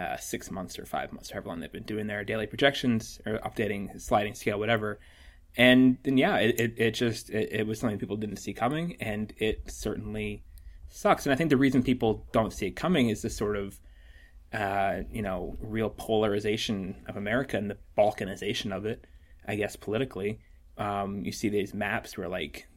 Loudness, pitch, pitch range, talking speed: -29 LUFS, 105 Hz, 100-115 Hz, 195 wpm